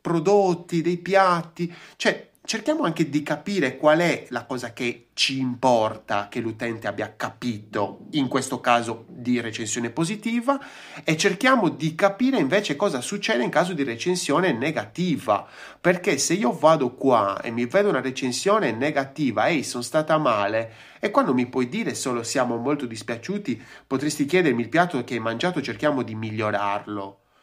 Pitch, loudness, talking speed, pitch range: 135 Hz, -23 LUFS, 160 wpm, 120-180 Hz